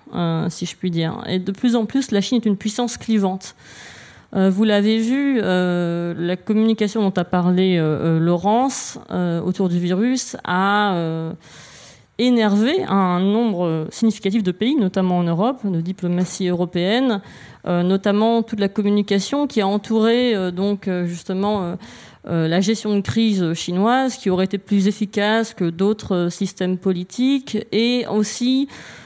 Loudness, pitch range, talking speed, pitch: -19 LUFS, 180-225 Hz, 160 wpm, 200 Hz